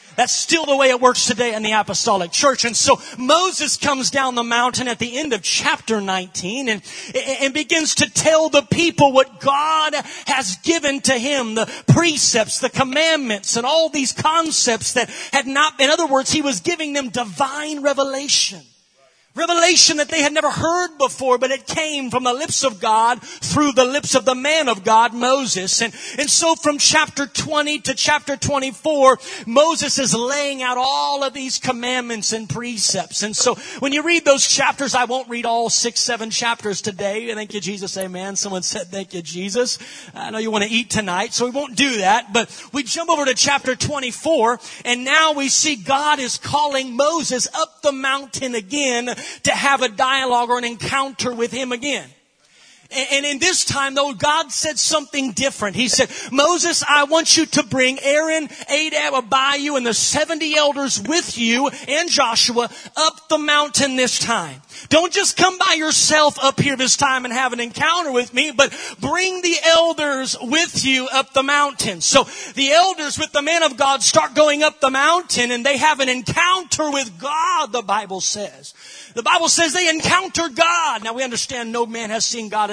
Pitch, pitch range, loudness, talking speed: 270 Hz, 240-300 Hz, -17 LUFS, 190 wpm